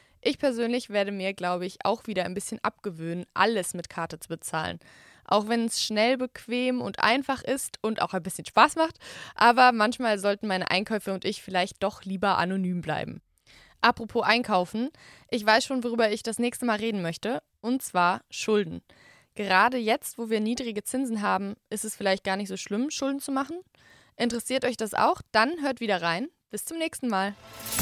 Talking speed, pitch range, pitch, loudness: 185 wpm, 190-245 Hz, 215 Hz, -27 LUFS